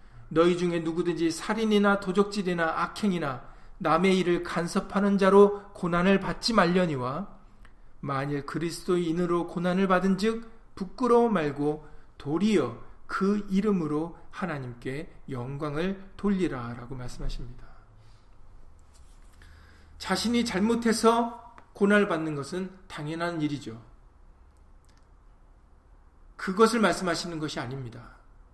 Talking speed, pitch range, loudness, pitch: 255 characters per minute, 120-195 Hz, -27 LUFS, 165 Hz